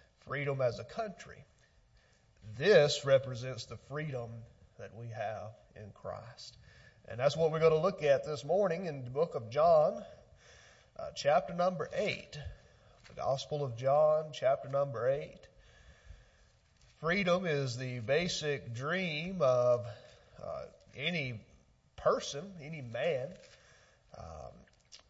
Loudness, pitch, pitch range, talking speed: -33 LUFS, 140 Hz, 120-155 Hz, 120 wpm